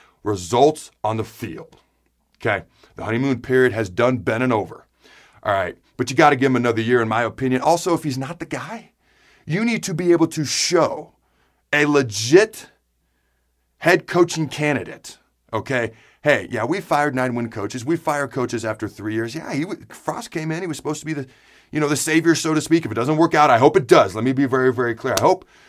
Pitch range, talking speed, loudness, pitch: 115-155 Hz, 220 wpm, -20 LUFS, 130 Hz